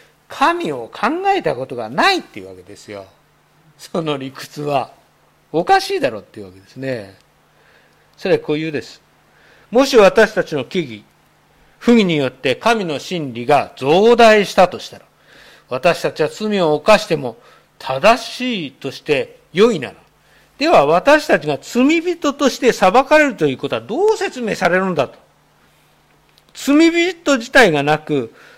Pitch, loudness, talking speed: 190 Hz, -16 LUFS, 280 characters per minute